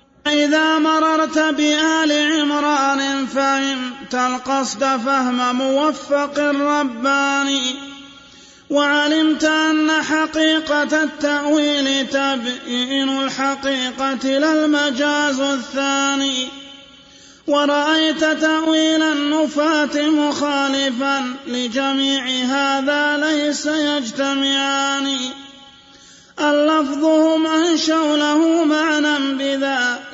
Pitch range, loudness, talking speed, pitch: 275-305 Hz, -17 LUFS, 60 wpm, 285 Hz